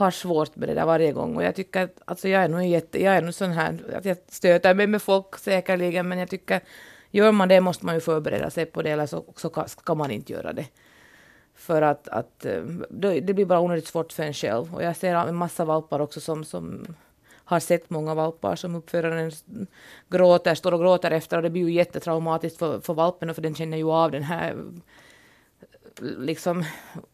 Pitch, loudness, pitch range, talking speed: 170 Hz, -24 LUFS, 160-185 Hz, 210 wpm